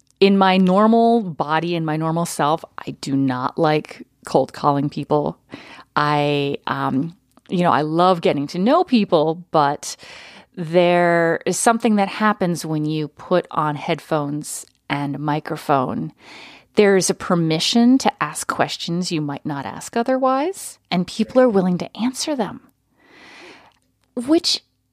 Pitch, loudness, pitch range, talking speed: 175 Hz, -19 LUFS, 150-210 Hz, 140 wpm